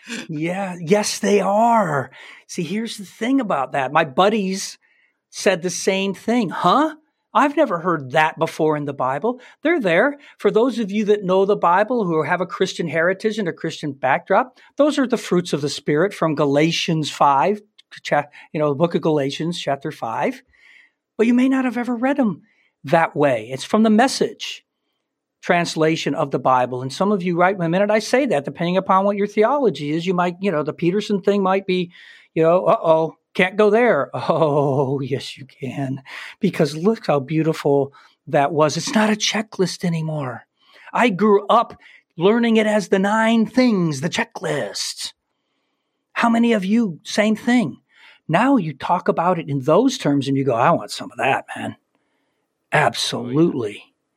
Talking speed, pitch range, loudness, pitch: 180 wpm, 160-220 Hz, -19 LUFS, 185 Hz